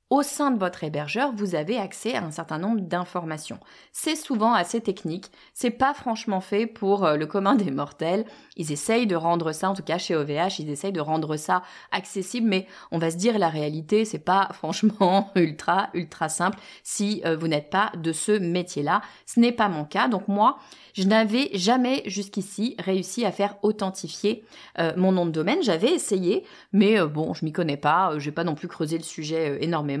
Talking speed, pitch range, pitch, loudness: 195 wpm, 160-215 Hz, 190 Hz, -25 LUFS